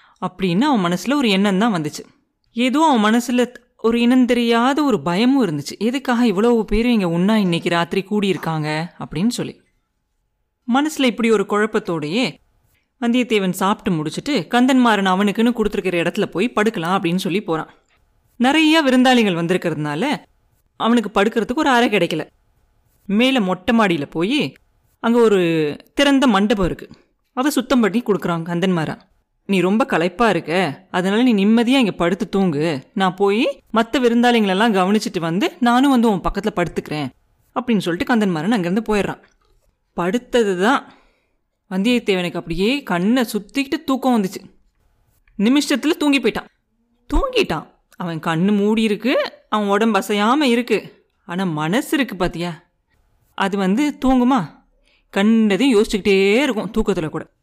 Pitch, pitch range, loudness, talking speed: 210 Hz, 185-245 Hz, -18 LUFS, 125 wpm